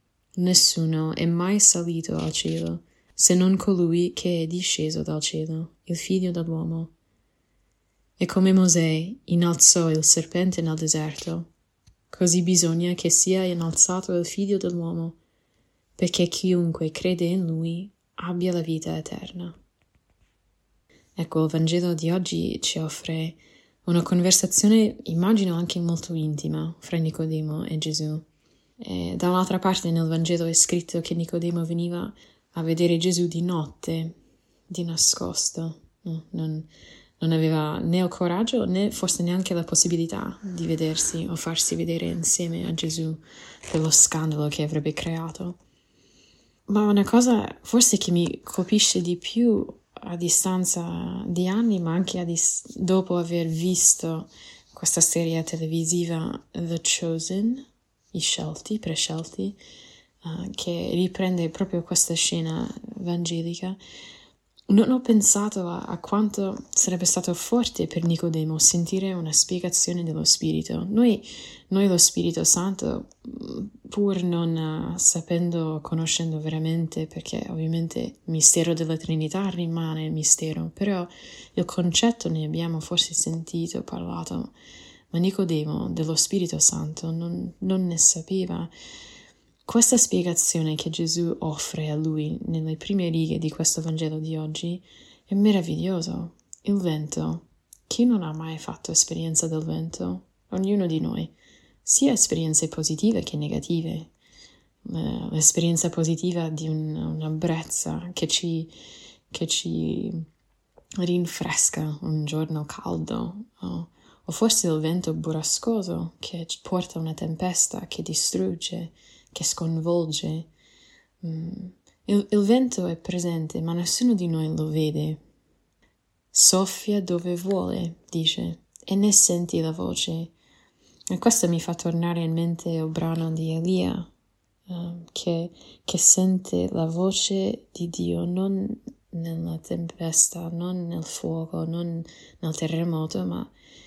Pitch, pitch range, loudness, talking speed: 170 Hz, 160-185 Hz, -23 LUFS, 125 wpm